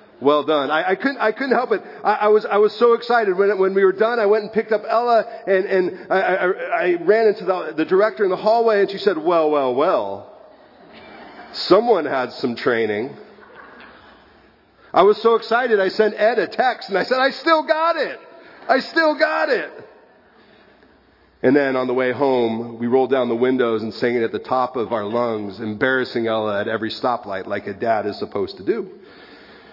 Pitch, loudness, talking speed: 195 Hz, -19 LUFS, 210 wpm